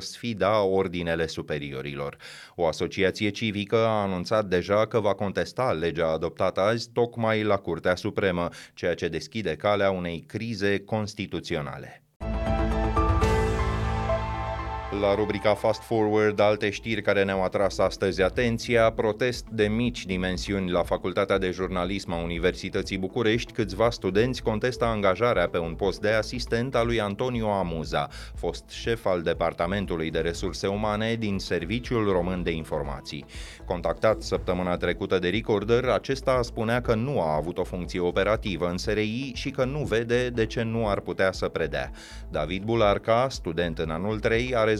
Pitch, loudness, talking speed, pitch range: 105 Hz, -26 LUFS, 145 wpm, 90-115 Hz